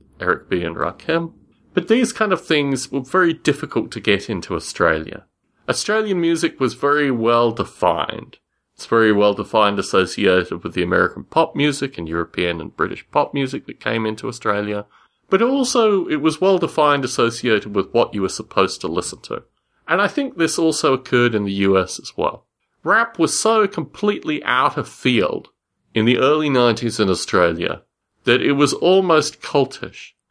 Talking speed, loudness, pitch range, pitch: 170 wpm, -19 LUFS, 115-170 Hz, 145 Hz